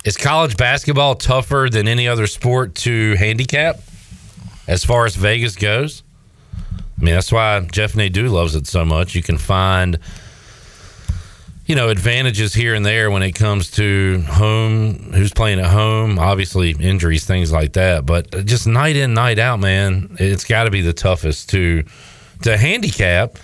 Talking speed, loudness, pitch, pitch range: 165 wpm, -16 LUFS, 105 Hz, 90-115 Hz